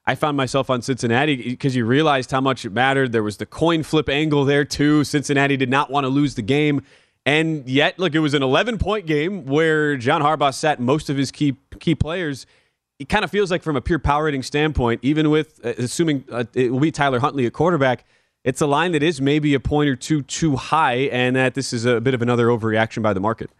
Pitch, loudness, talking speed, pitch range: 140 Hz, -20 LUFS, 240 wpm, 125-150 Hz